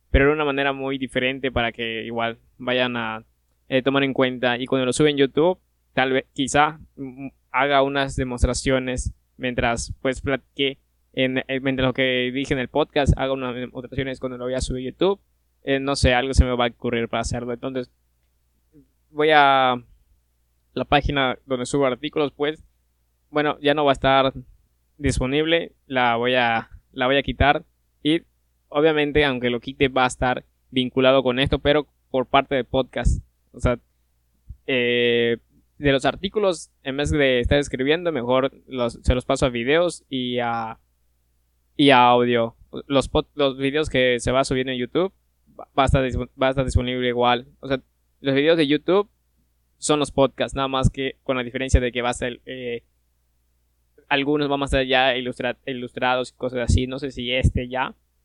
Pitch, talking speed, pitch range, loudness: 130 Hz, 180 wpm, 115-135 Hz, -22 LUFS